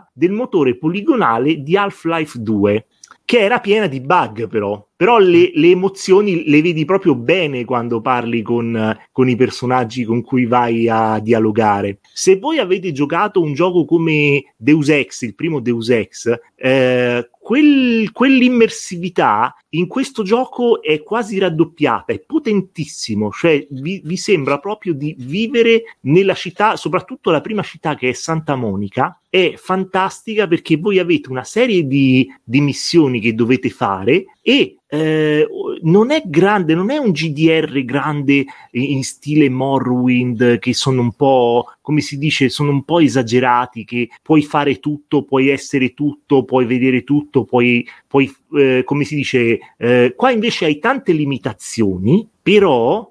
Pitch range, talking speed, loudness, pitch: 125-185 Hz, 150 wpm, -15 LUFS, 145 Hz